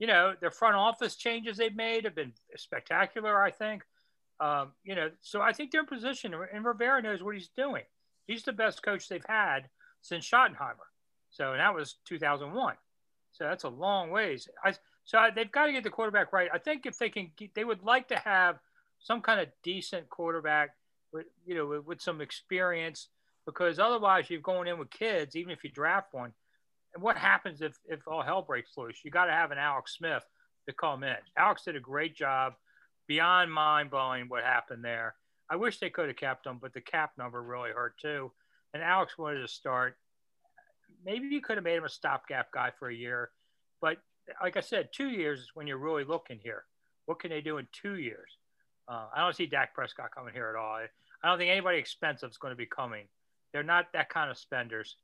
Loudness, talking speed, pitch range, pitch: -31 LUFS, 215 wpm, 150-220 Hz, 175 Hz